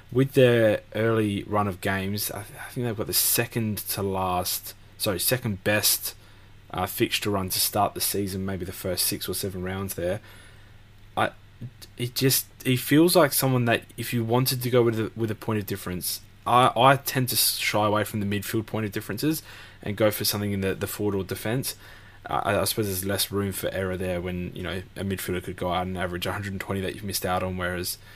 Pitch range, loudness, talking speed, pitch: 95-110 Hz, -25 LUFS, 215 wpm, 100 Hz